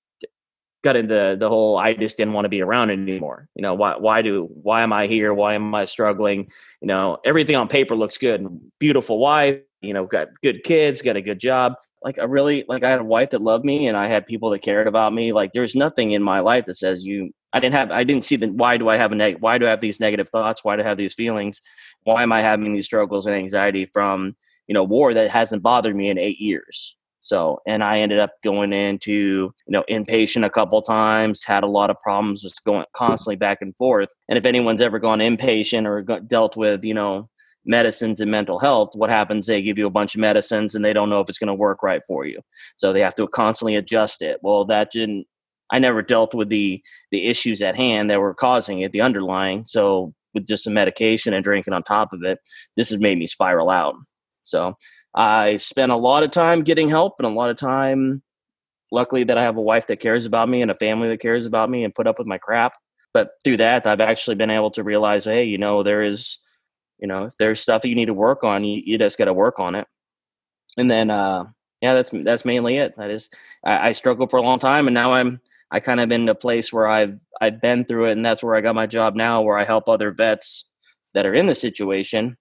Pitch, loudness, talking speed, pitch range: 110 Hz, -19 LUFS, 245 wpm, 105-120 Hz